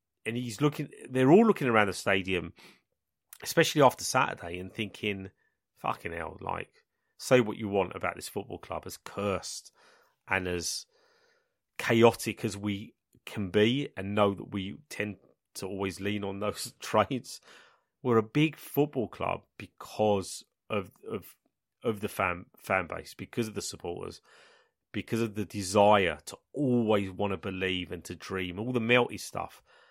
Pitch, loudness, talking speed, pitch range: 105 Hz, -30 LUFS, 155 wpm, 95-125 Hz